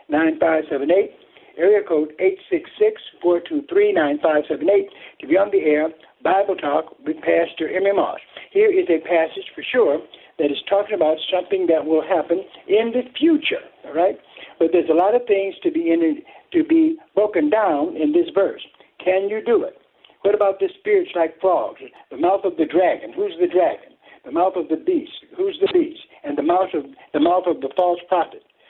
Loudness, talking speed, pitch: -20 LUFS, 205 wpm, 205 Hz